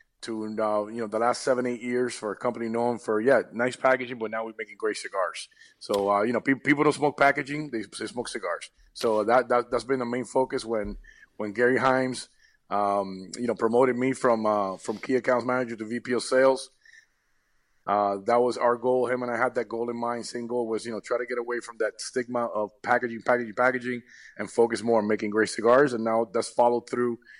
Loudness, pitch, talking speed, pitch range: -26 LUFS, 120 Hz, 225 wpm, 110-125 Hz